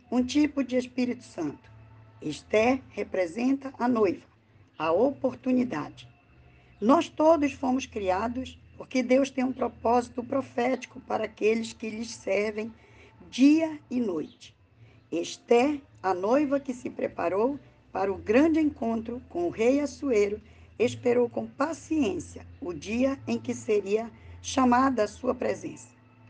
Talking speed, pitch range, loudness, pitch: 125 wpm, 205-265 Hz, -27 LUFS, 245 Hz